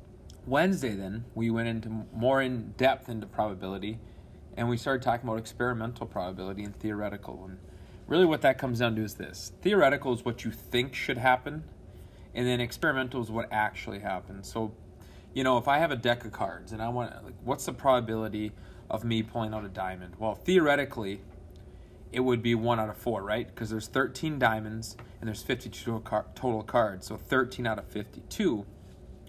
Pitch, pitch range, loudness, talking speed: 110 Hz, 100-120 Hz, -30 LUFS, 180 wpm